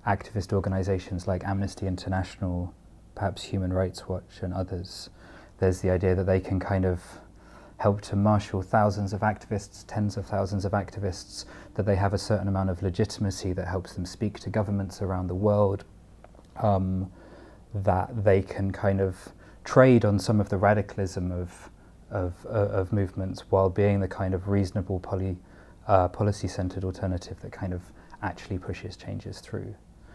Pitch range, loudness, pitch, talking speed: 95-100 Hz, -28 LUFS, 95 Hz, 160 wpm